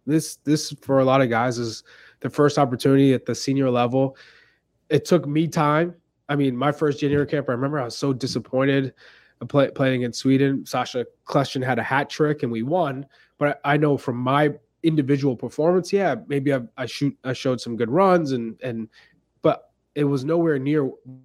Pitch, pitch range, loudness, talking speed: 140 Hz, 130-150 Hz, -22 LUFS, 195 wpm